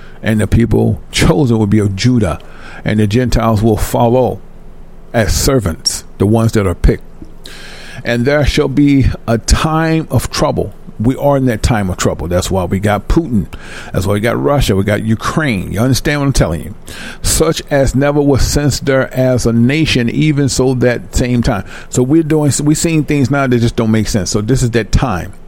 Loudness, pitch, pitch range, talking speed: -13 LUFS, 120 Hz, 110-140 Hz, 200 wpm